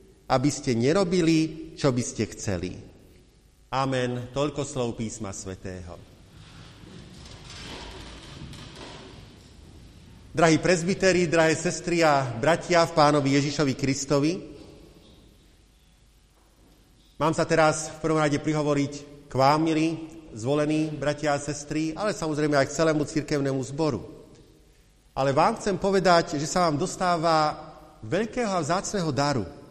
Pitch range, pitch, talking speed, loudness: 135-160 Hz, 150 Hz, 110 wpm, -25 LUFS